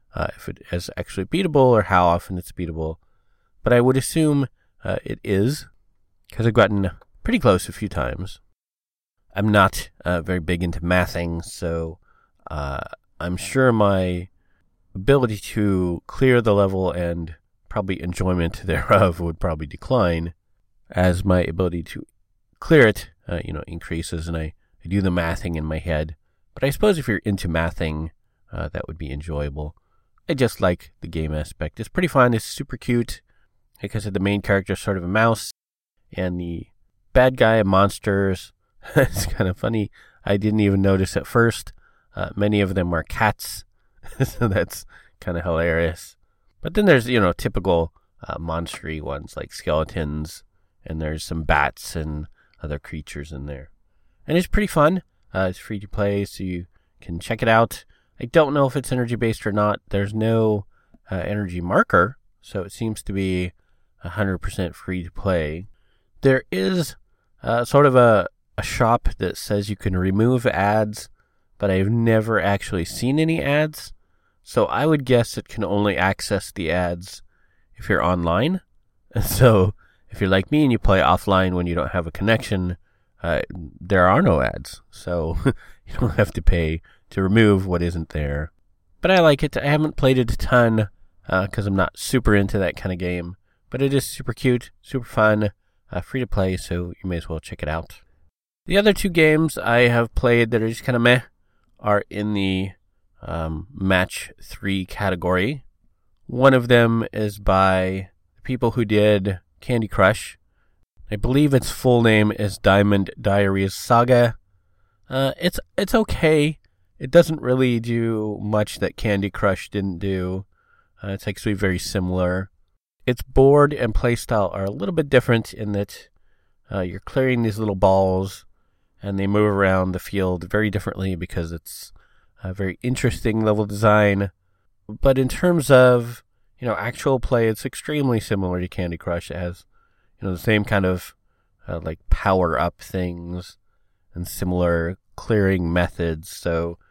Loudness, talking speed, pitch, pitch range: -21 LUFS, 170 wpm, 95 Hz, 90-115 Hz